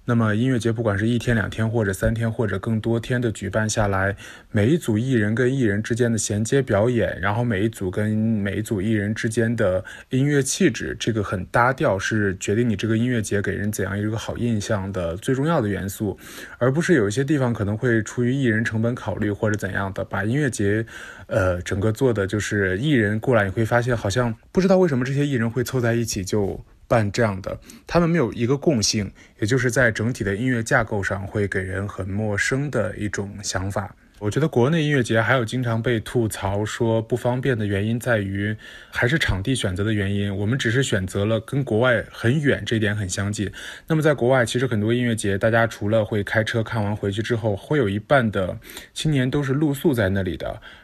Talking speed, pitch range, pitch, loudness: 325 characters per minute, 105-125 Hz, 115 Hz, -22 LUFS